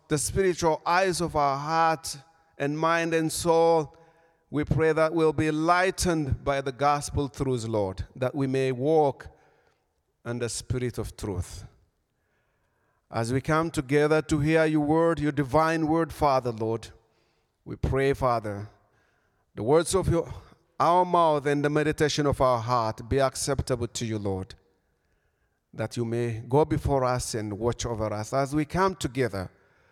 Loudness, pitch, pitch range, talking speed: -26 LUFS, 140 Hz, 115-160 Hz, 155 wpm